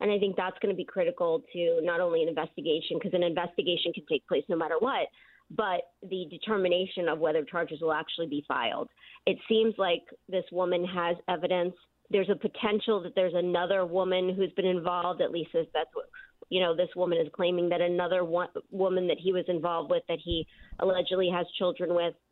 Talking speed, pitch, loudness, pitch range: 200 wpm, 180 Hz, -29 LUFS, 175-195 Hz